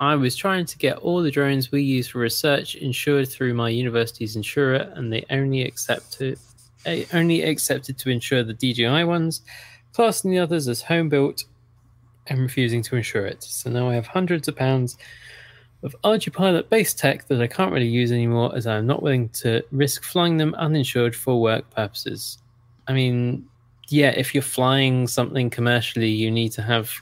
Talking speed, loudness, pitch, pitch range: 185 wpm, -22 LUFS, 130 Hz, 120-145 Hz